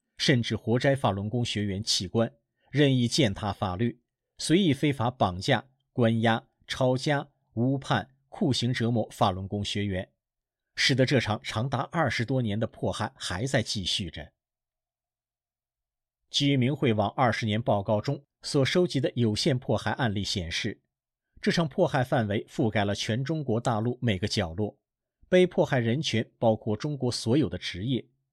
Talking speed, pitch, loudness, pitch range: 235 characters per minute, 120 Hz, -27 LUFS, 105-135 Hz